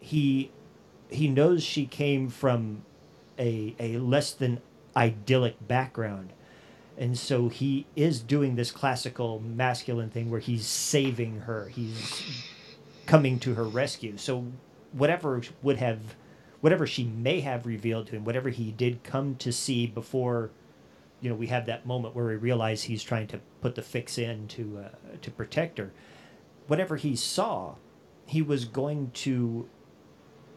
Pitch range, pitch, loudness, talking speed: 110-135 Hz, 120 Hz, -29 LUFS, 150 wpm